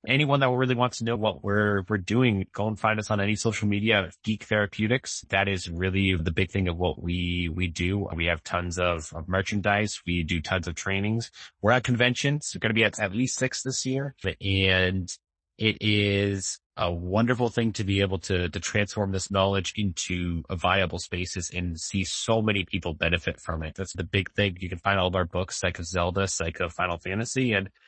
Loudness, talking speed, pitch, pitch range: -26 LUFS, 205 wpm, 95 Hz, 90-110 Hz